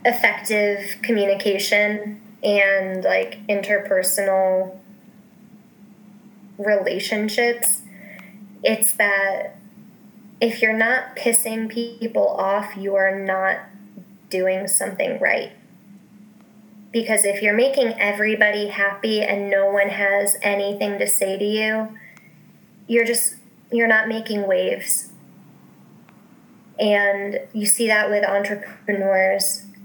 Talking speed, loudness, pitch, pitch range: 90 wpm, -20 LUFS, 205 Hz, 200-220 Hz